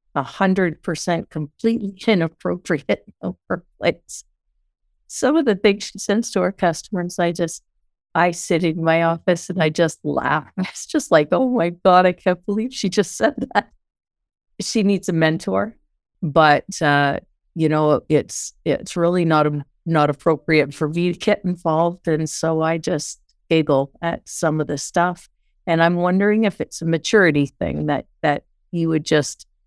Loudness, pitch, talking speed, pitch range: -20 LUFS, 170 Hz, 165 wpm, 160-190 Hz